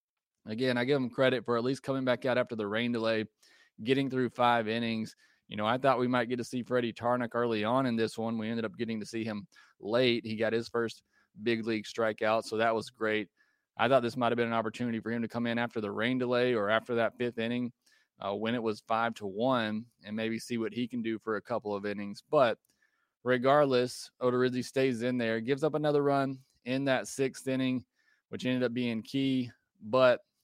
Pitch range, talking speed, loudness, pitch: 110-125 Hz, 225 wpm, -31 LUFS, 120 Hz